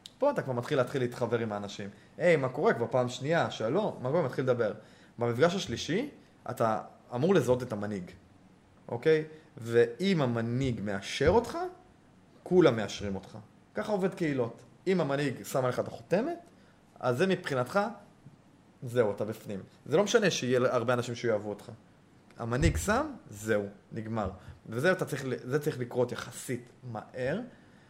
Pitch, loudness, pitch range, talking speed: 125 Hz, -30 LUFS, 110-155 Hz, 145 wpm